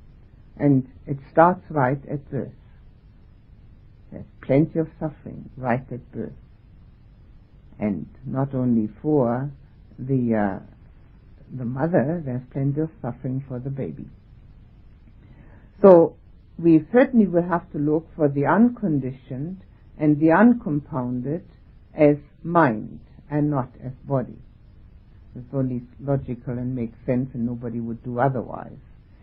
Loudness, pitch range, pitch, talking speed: -22 LUFS, 120-150 Hz, 130 Hz, 120 wpm